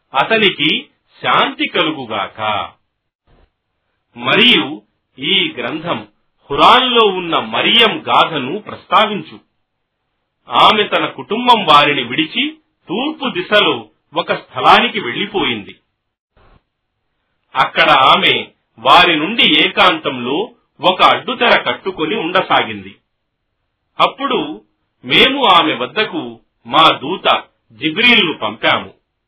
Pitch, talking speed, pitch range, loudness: 210 Hz, 80 wpm, 155-245 Hz, -13 LUFS